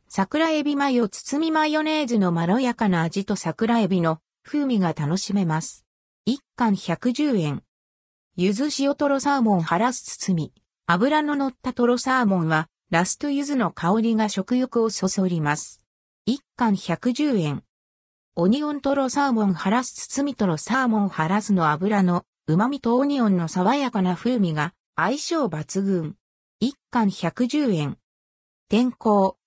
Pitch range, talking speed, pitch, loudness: 170-255 Hz, 270 characters per minute, 210 Hz, -23 LUFS